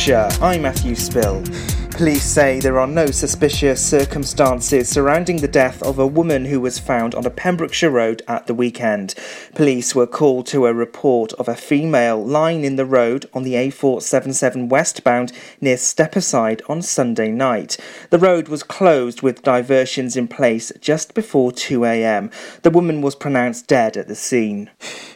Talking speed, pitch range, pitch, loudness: 160 wpm, 125-150 Hz, 135 Hz, -17 LUFS